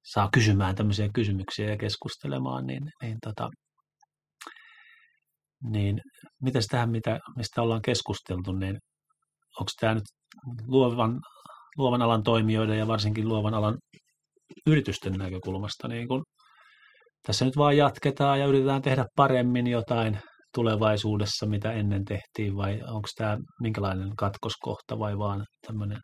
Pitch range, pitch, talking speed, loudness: 105-135 Hz, 115 Hz, 120 wpm, -28 LUFS